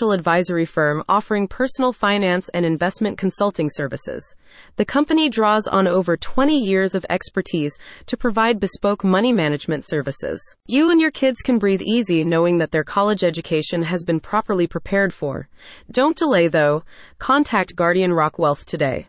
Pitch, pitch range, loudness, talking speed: 190 Hz, 165-220 Hz, -19 LUFS, 155 wpm